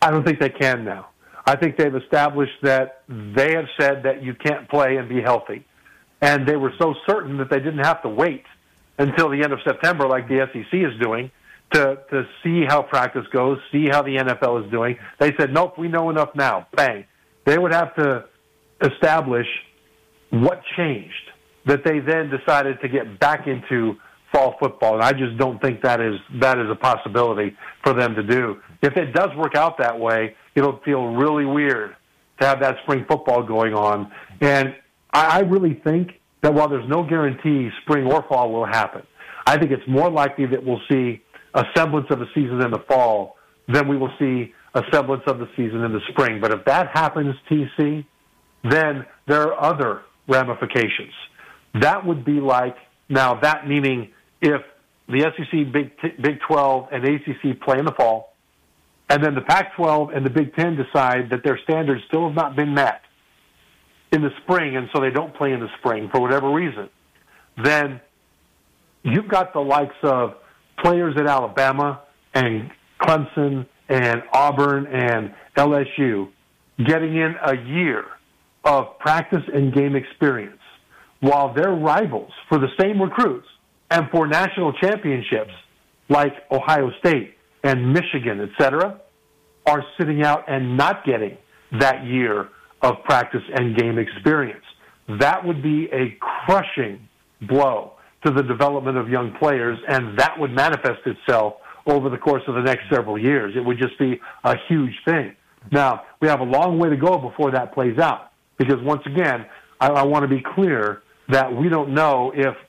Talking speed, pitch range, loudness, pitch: 175 wpm, 125-150 Hz, -20 LUFS, 140 Hz